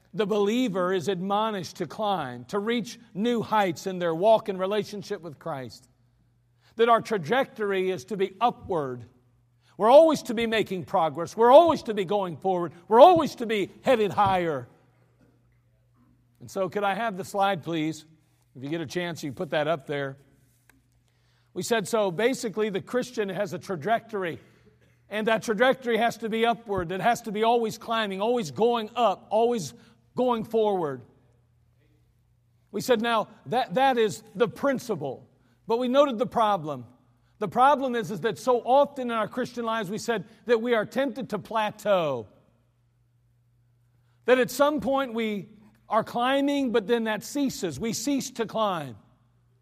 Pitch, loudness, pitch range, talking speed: 205 Hz, -25 LUFS, 140-230 Hz, 165 wpm